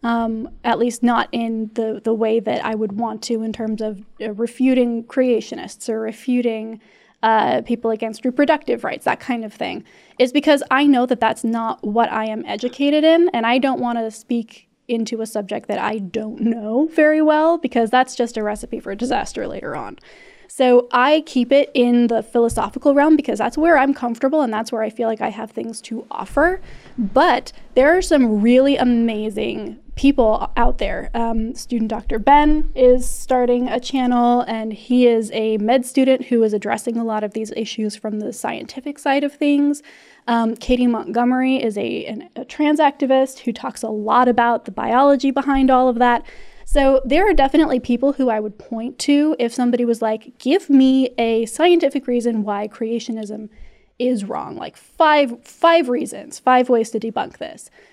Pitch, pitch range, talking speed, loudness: 240 Hz, 225-270 Hz, 185 wpm, -18 LUFS